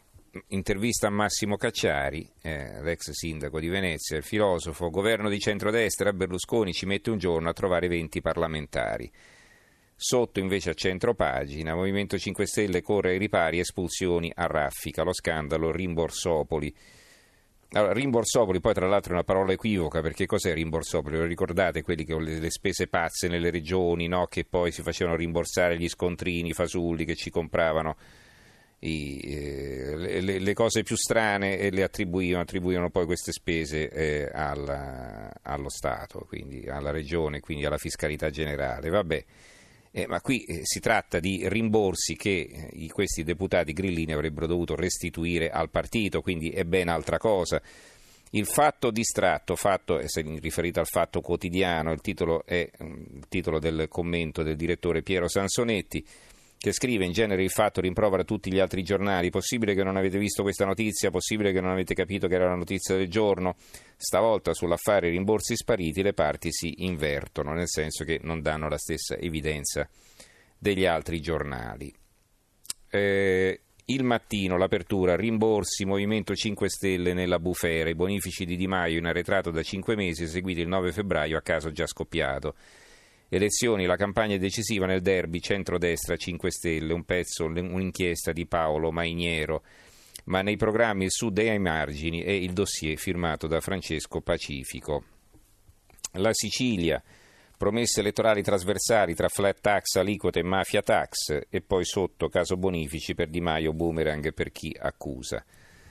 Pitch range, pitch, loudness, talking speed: 80-100 Hz, 90 Hz, -27 LUFS, 150 wpm